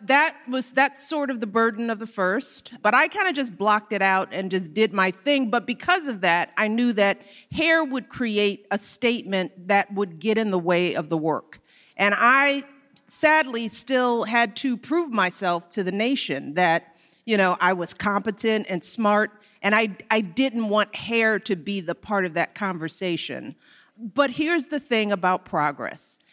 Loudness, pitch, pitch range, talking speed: -23 LUFS, 215 Hz, 190-250 Hz, 185 wpm